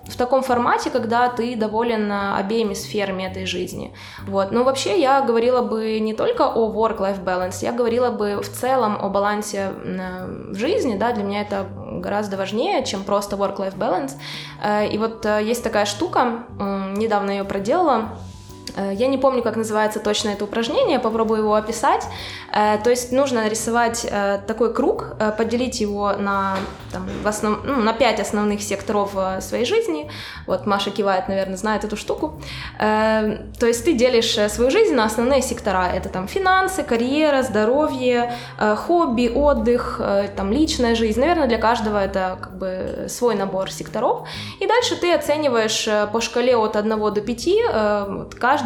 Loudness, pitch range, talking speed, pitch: -20 LUFS, 200-245 Hz, 155 wpm, 220 Hz